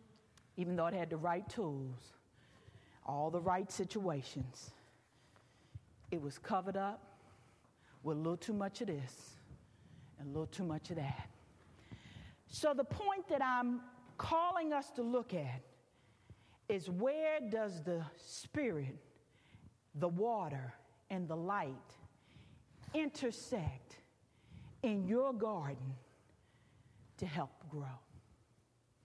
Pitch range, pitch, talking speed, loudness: 125-195 Hz, 150 Hz, 115 wpm, -40 LUFS